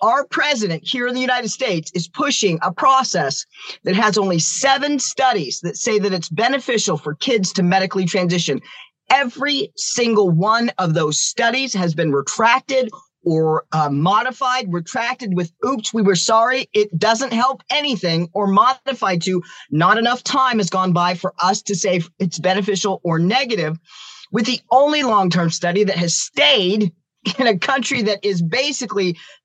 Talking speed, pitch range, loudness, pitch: 160 wpm, 175-245 Hz, -18 LUFS, 205 Hz